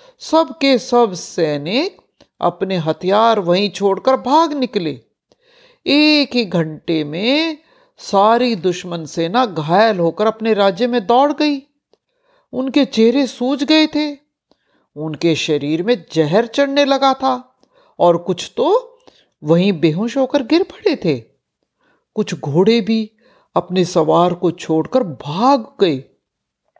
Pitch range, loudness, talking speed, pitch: 175-280 Hz, -16 LUFS, 120 wpm, 230 Hz